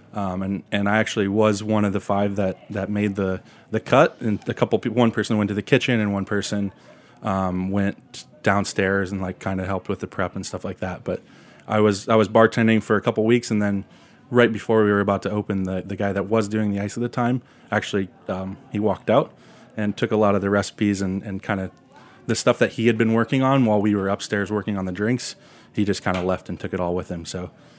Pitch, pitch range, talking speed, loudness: 105 Hz, 95-110 Hz, 260 wpm, -22 LUFS